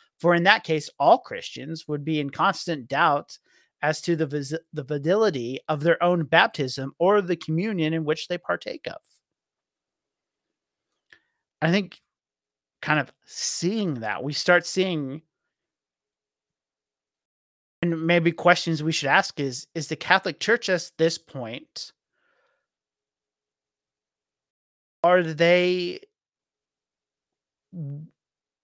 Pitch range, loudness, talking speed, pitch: 130-175 Hz, -23 LUFS, 115 wpm, 160 Hz